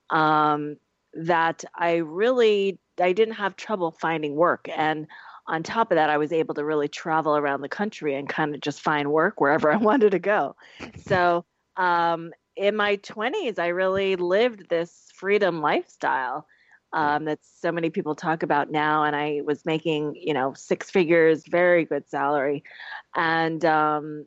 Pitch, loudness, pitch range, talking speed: 160 Hz, -24 LUFS, 150-180 Hz, 165 wpm